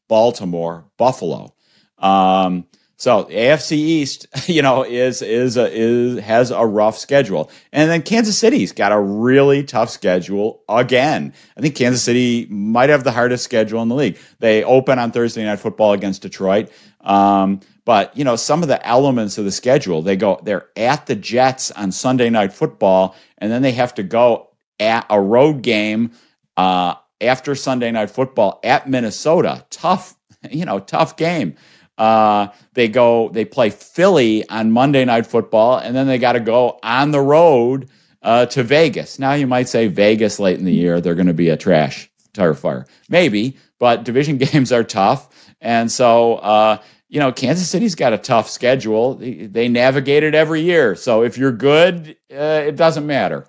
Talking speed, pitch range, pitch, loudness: 180 wpm, 105-135 Hz, 120 Hz, -16 LUFS